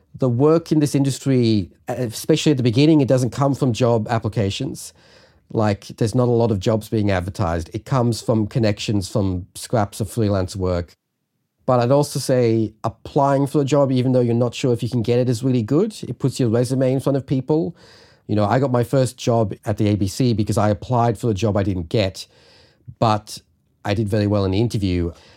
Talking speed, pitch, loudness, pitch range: 210 wpm, 120 Hz, -20 LUFS, 105-130 Hz